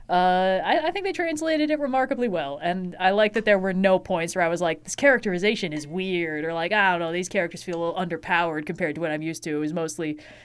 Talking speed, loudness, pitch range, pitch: 260 wpm, -24 LUFS, 165-210 Hz, 180 Hz